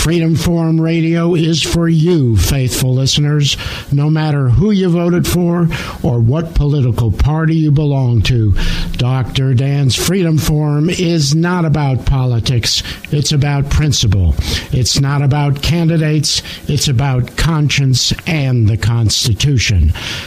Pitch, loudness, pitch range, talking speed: 140 Hz, -13 LUFS, 120-160 Hz, 125 wpm